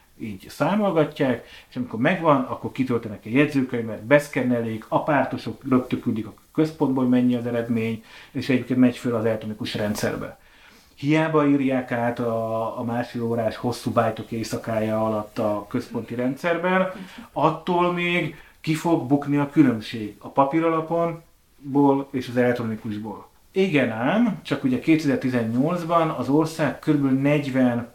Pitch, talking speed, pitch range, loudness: 125 Hz, 125 wpm, 115-150 Hz, -23 LUFS